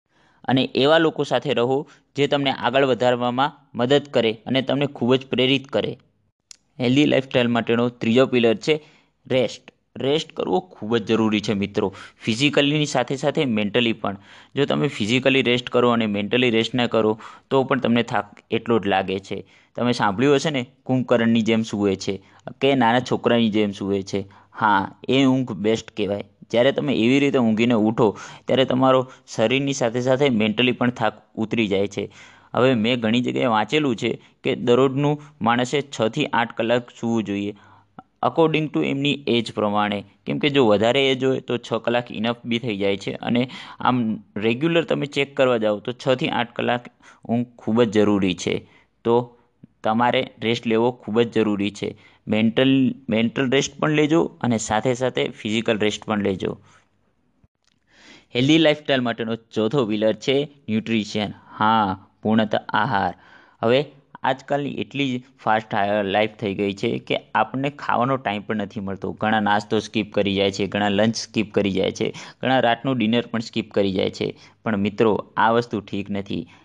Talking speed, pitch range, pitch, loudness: 165 wpm, 105-130 Hz, 115 Hz, -21 LUFS